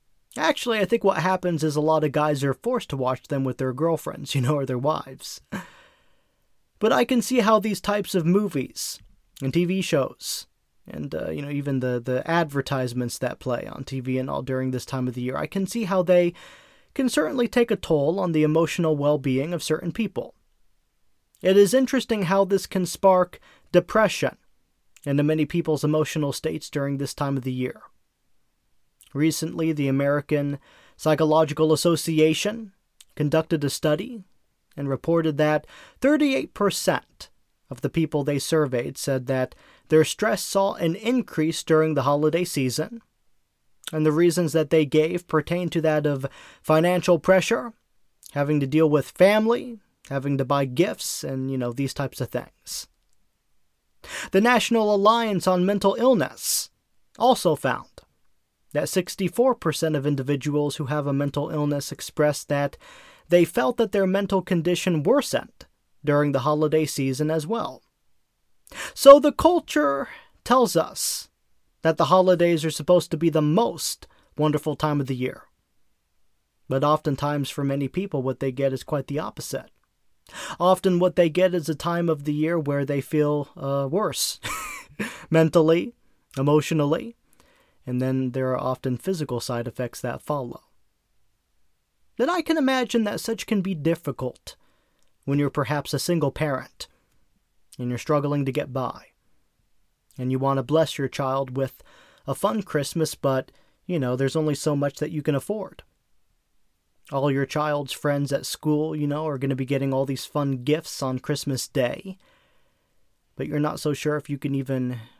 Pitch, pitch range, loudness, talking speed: 155 Hz, 140-180 Hz, -23 LUFS, 160 wpm